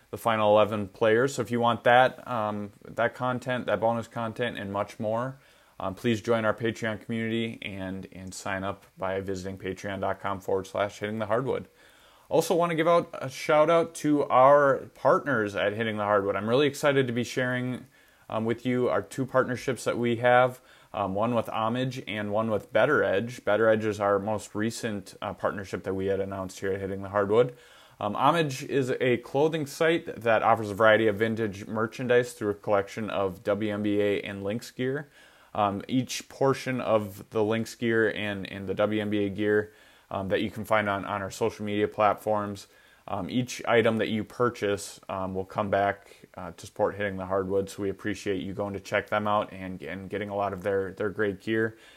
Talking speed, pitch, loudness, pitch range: 195 wpm, 105 Hz, -27 LUFS, 100-120 Hz